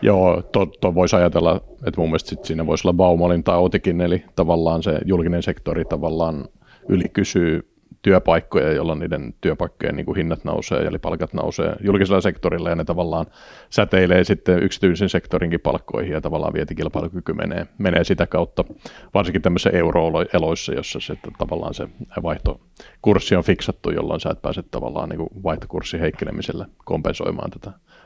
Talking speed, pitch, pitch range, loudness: 150 wpm, 90 Hz, 80-95 Hz, -21 LUFS